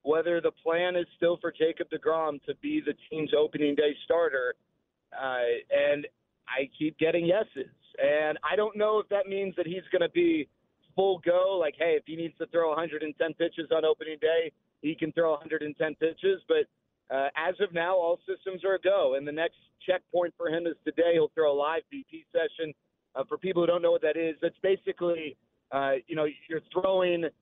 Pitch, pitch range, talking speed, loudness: 170 Hz, 155-190 Hz, 200 wpm, -29 LUFS